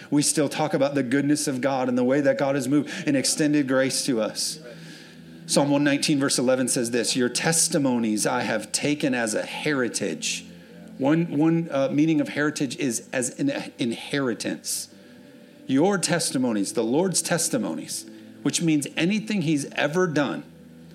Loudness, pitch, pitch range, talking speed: -24 LUFS, 150 Hz, 135-175 Hz, 160 wpm